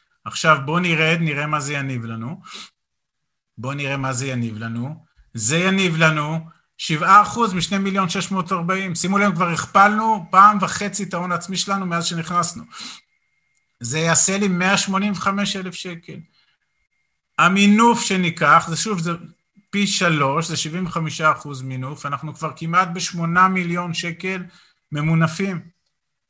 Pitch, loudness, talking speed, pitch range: 175 Hz, -19 LUFS, 130 wpm, 155-190 Hz